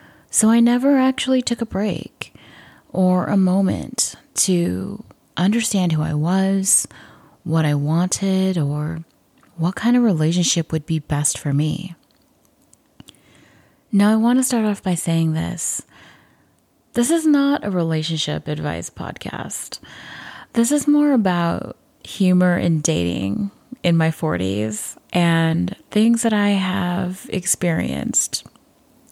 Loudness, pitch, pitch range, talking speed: -19 LUFS, 180 Hz, 160-210 Hz, 125 wpm